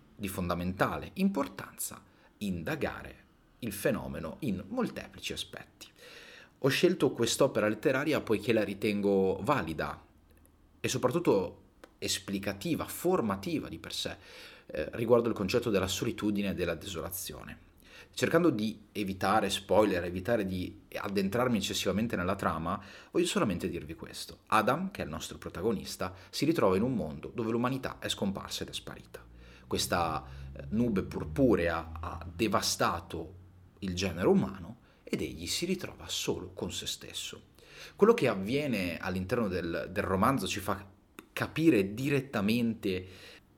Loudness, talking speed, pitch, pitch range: -32 LUFS, 125 wpm, 100 Hz, 90-115 Hz